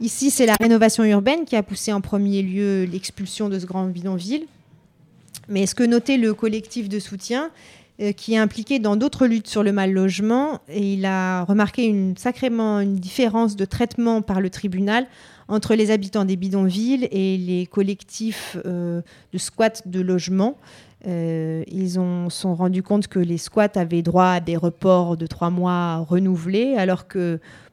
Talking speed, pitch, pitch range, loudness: 175 wpm, 195 Hz, 185-220 Hz, -21 LUFS